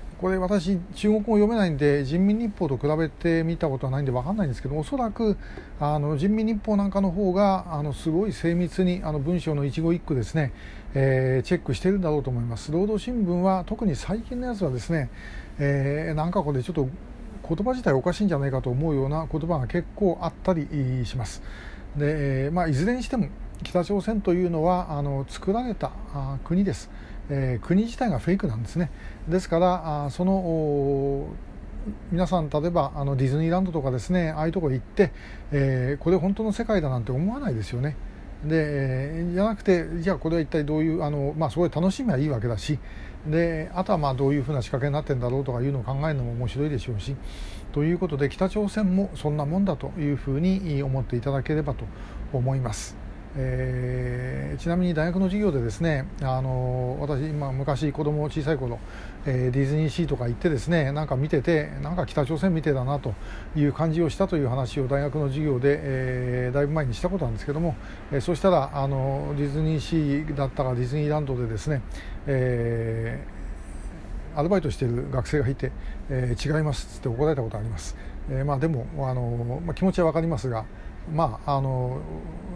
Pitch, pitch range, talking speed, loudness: 150 Hz, 130-175 Hz, 395 characters per minute, -26 LUFS